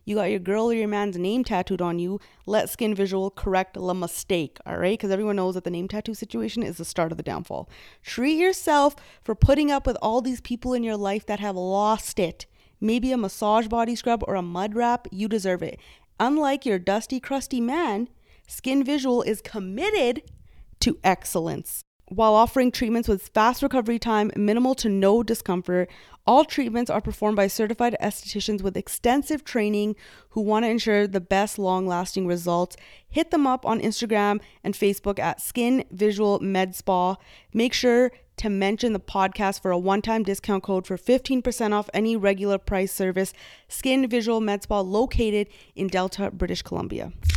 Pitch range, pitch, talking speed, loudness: 195-240 Hz, 210 Hz, 180 wpm, -24 LUFS